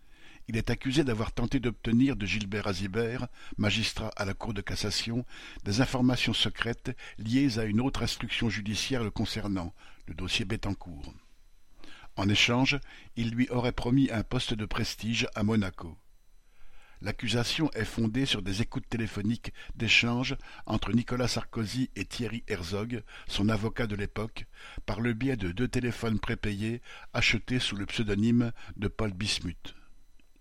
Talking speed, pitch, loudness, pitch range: 145 wpm, 115 Hz, -30 LUFS, 105-120 Hz